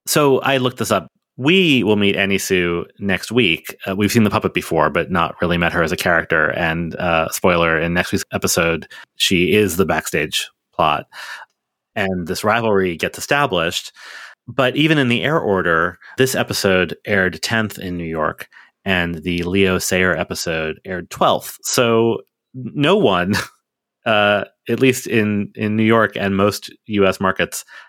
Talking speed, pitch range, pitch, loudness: 165 wpm, 90-115 Hz, 100 Hz, -17 LUFS